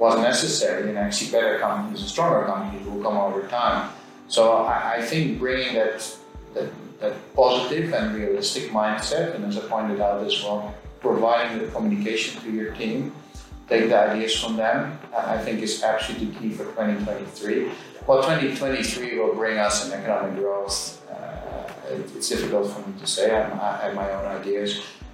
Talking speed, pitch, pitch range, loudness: 165 wpm, 110 Hz, 100-115 Hz, -24 LUFS